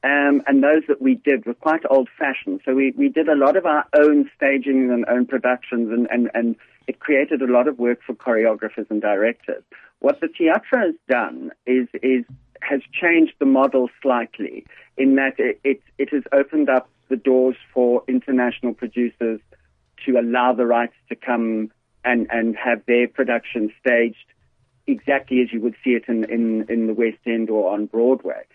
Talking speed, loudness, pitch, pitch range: 185 wpm, -20 LUFS, 125 Hz, 120-140 Hz